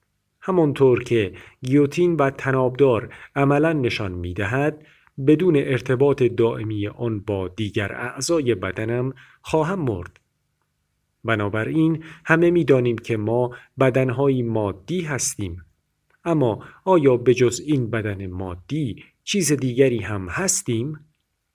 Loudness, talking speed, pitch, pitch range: -21 LUFS, 105 wpm, 125 Hz, 110-145 Hz